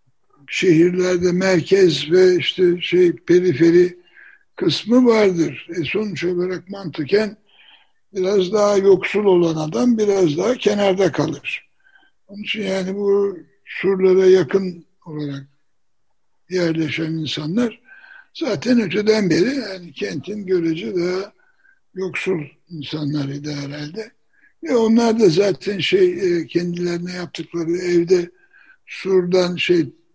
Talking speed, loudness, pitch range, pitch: 100 wpm, -18 LUFS, 170-210 Hz, 185 Hz